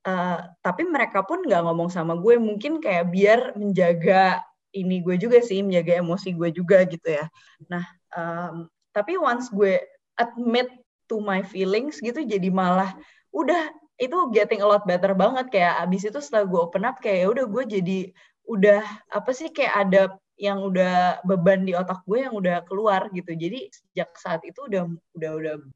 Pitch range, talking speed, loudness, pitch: 180-225 Hz, 170 wpm, -23 LUFS, 195 Hz